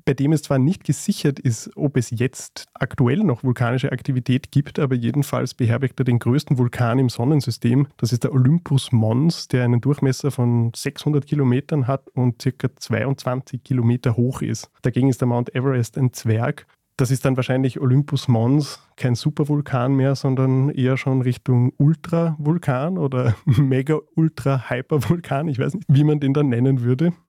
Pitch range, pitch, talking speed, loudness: 125-145 Hz, 135 Hz, 165 wpm, -20 LUFS